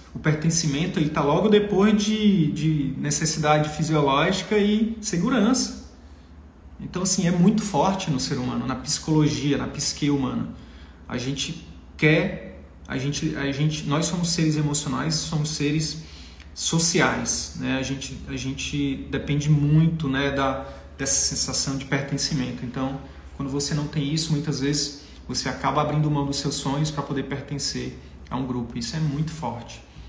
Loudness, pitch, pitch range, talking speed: -23 LUFS, 145 Hz, 135-155 Hz, 150 wpm